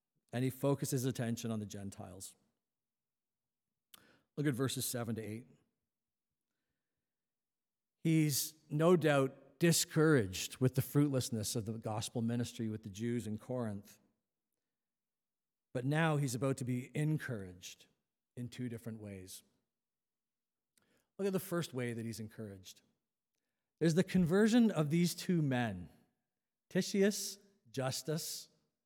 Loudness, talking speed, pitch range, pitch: -35 LUFS, 120 wpm, 115-155 Hz, 130 Hz